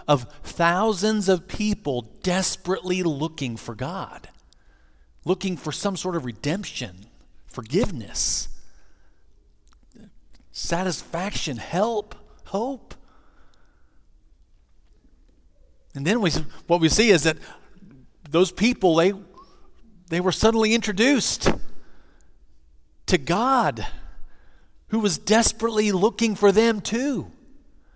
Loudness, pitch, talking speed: -23 LUFS, 175 Hz, 90 wpm